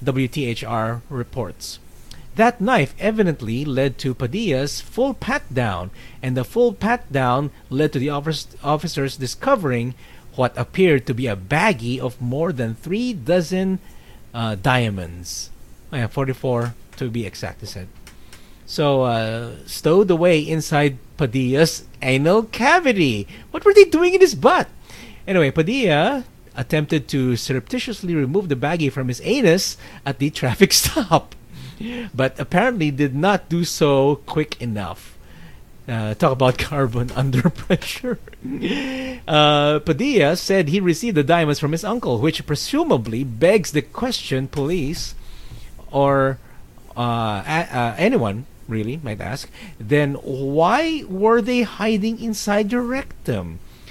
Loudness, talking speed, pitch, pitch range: -20 LUFS, 130 wpm, 145 Hz, 125-185 Hz